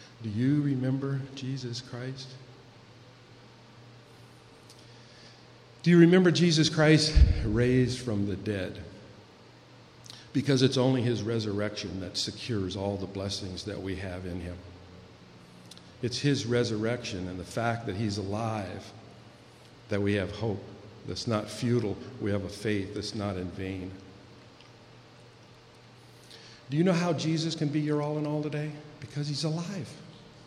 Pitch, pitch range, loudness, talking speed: 120 Hz, 100-130 Hz, -29 LUFS, 135 wpm